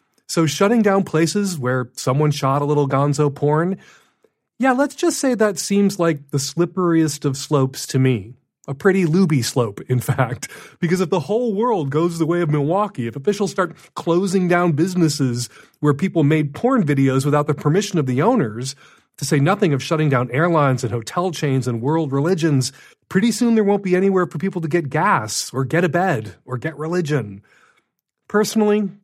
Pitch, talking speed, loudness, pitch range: 160 Hz, 185 wpm, -19 LUFS, 140-190 Hz